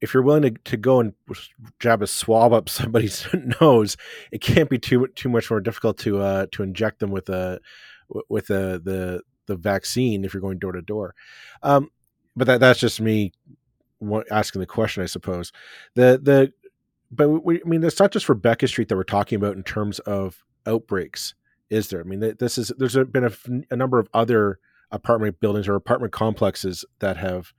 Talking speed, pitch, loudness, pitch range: 190 wpm, 110 Hz, -21 LUFS, 100-125 Hz